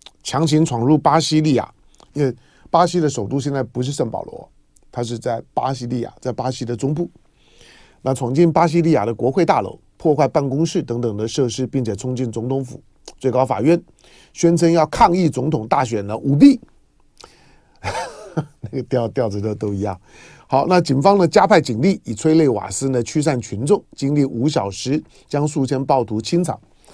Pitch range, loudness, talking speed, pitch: 120-160 Hz, -18 LUFS, 265 characters per minute, 135 Hz